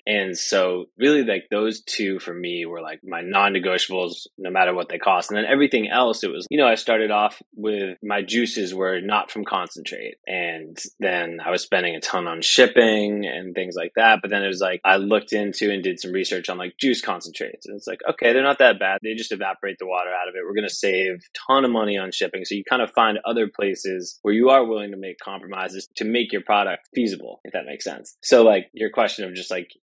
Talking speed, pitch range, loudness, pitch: 240 wpm, 90-110 Hz, -21 LUFS, 100 Hz